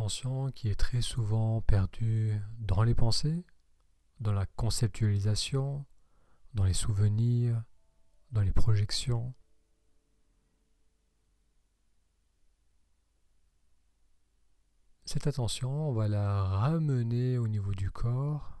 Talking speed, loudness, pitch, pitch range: 85 wpm, -31 LUFS, 105 Hz, 75-120 Hz